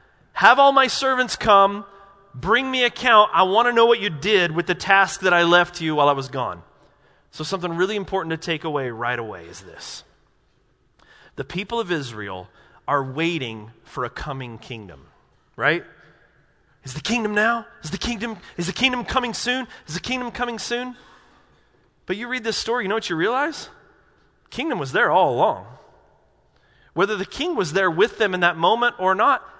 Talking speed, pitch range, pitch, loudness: 185 wpm, 155-235 Hz, 190 Hz, -20 LUFS